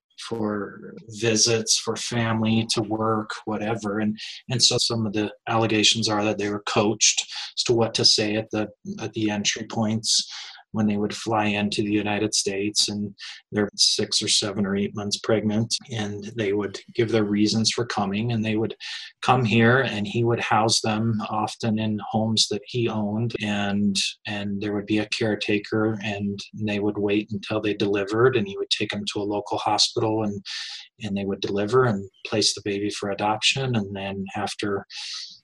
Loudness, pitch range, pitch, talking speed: -23 LUFS, 105-110 Hz, 105 Hz, 185 wpm